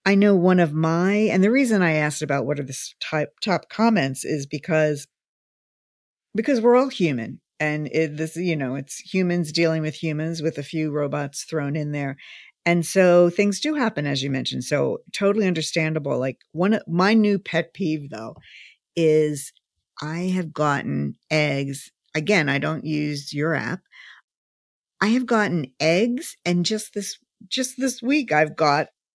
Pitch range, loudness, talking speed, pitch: 150-200 Hz, -22 LUFS, 165 wpm, 160 Hz